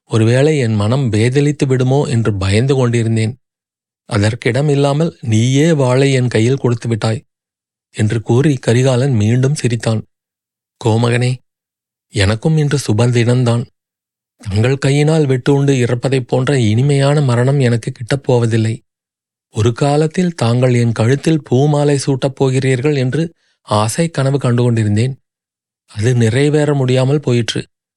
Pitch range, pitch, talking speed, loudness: 115-140 Hz, 130 Hz, 110 wpm, -14 LUFS